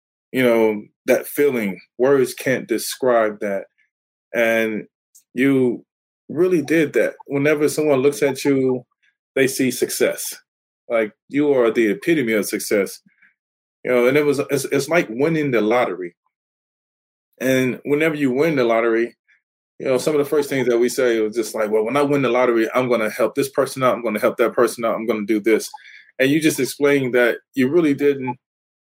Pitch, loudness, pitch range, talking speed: 130 Hz, -19 LUFS, 115-150 Hz, 190 wpm